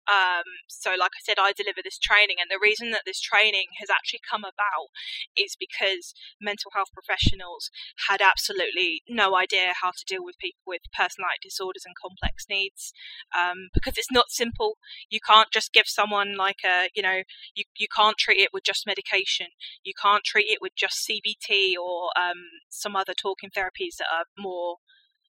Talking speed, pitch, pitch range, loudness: 185 wpm, 205 Hz, 190-240 Hz, -24 LUFS